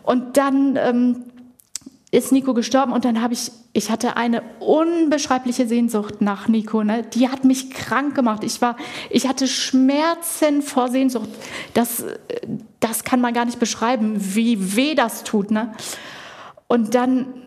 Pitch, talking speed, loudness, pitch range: 245 Hz, 150 wpm, -20 LUFS, 230-265 Hz